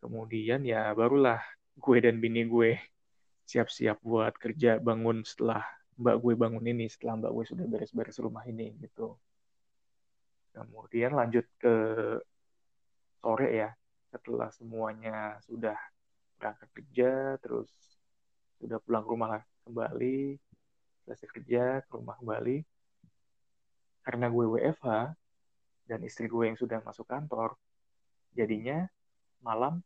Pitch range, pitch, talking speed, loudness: 110-120 Hz, 115 Hz, 115 wpm, -32 LUFS